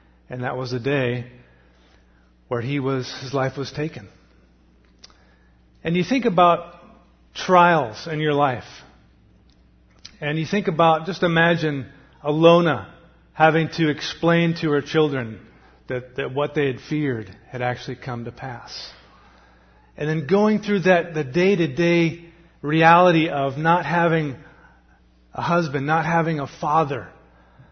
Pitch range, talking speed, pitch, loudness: 110-165 Hz, 135 wpm, 145 Hz, -21 LUFS